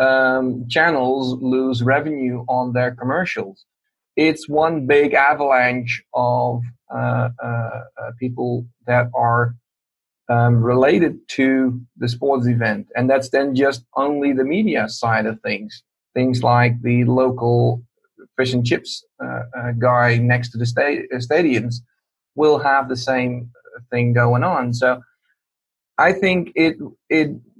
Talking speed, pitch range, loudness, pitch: 135 wpm, 120-135 Hz, -18 LUFS, 125 Hz